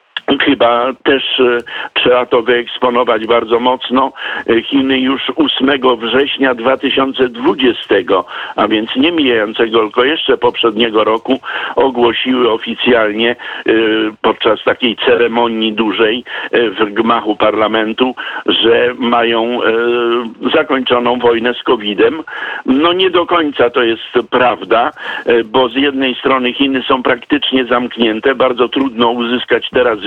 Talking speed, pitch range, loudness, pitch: 110 wpm, 115-135 Hz, -12 LUFS, 125 Hz